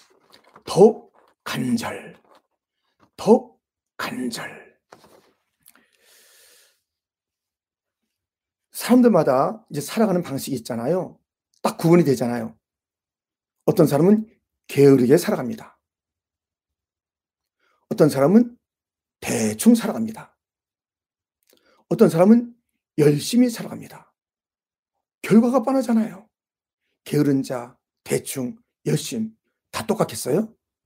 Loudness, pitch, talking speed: -20 LUFS, 185 Hz, 180 characters per minute